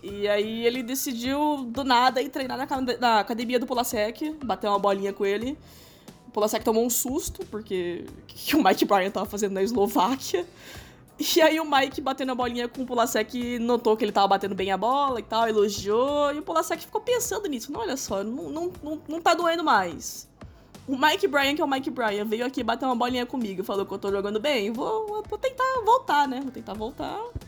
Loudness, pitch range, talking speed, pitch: -25 LUFS, 215-305 Hz, 215 wpm, 255 Hz